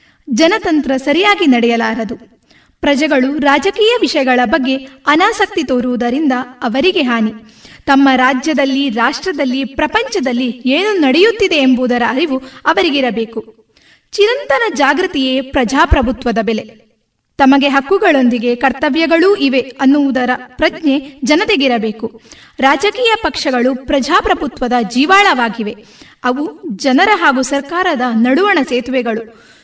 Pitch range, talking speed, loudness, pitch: 250-320 Hz, 85 wpm, -13 LUFS, 275 Hz